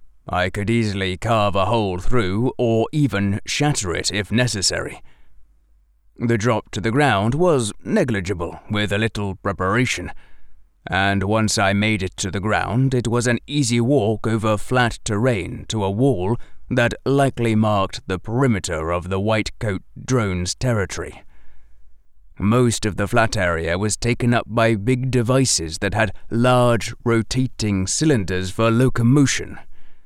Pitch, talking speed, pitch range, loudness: 110 Hz, 145 wpm, 95-120 Hz, -20 LUFS